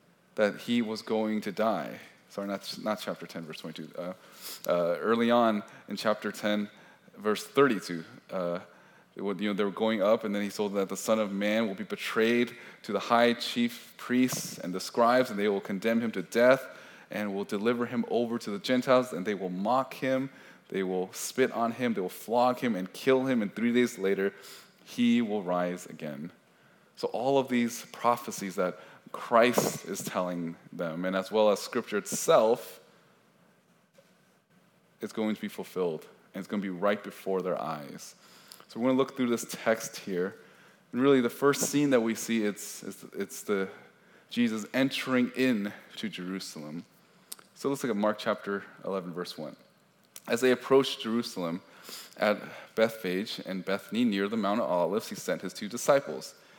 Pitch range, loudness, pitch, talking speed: 100-125 Hz, -30 LUFS, 110 Hz, 185 wpm